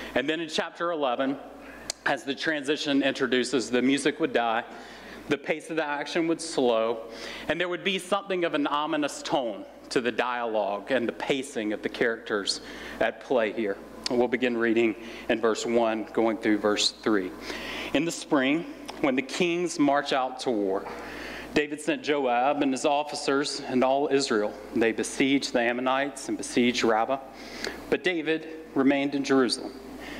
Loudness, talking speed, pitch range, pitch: -27 LUFS, 165 wpm, 120-155 Hz, 135 Hz